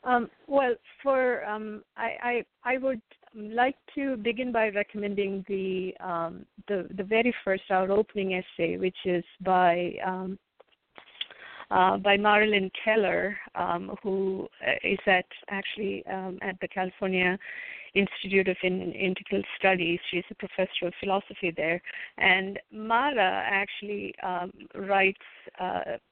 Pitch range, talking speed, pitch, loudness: 185-215 Hz, 125 wpm, 195 Hz, -28 LUFS